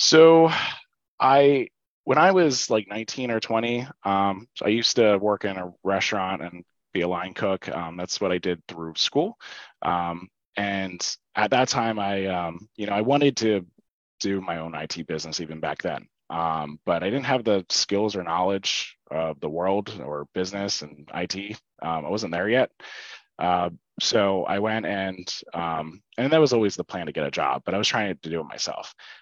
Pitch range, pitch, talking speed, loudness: 90-110 Hz, 95 Hz, 195 wpm, -24 LUFS